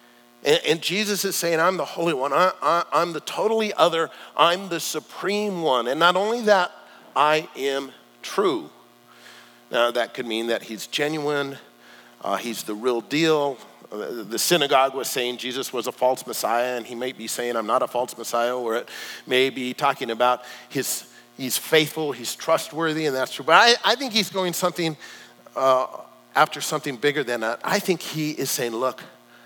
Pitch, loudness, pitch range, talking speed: 140 Hz, -23 LUFS, 120-165 Hz, 180 wpm